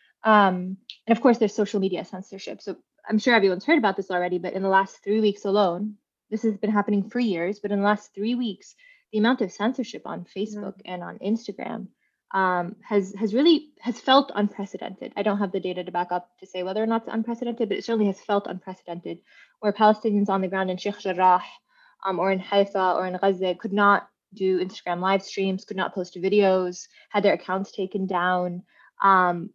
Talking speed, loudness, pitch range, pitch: 210 wpm, -24 LUFS, 185-215 Hz, 200 Hz